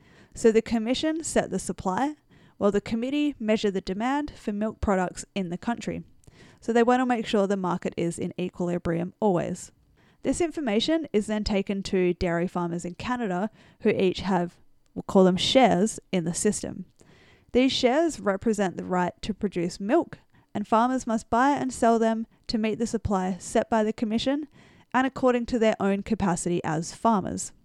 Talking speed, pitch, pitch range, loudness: 175 wpm, 215 Hz, 185-235 Hz, -26 LUFS